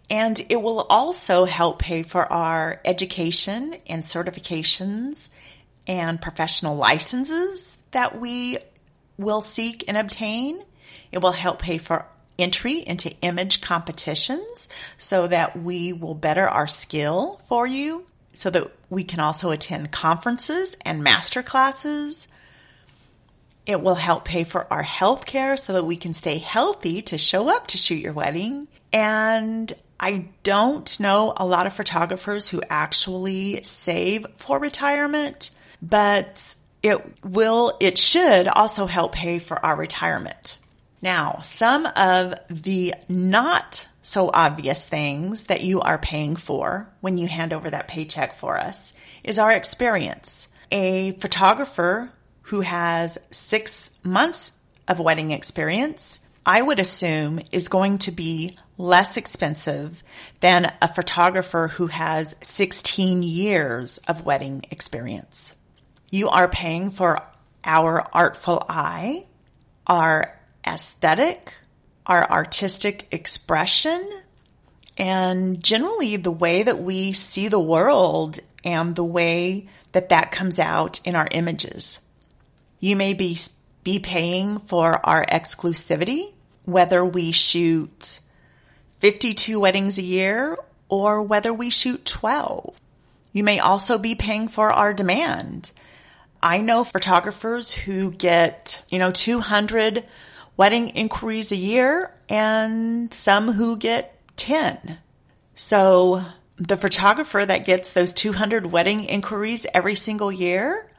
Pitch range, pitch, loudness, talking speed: 170-215 Hz, 185 Hz, -21 LUFS, 125 wpm